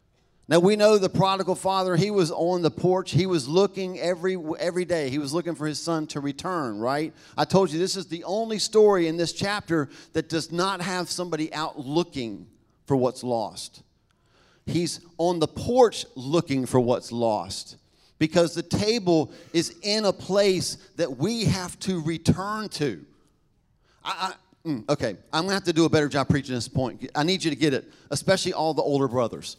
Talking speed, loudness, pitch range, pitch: 190 wpm, -25 LUFS, 150-185 Hz, 170 Hz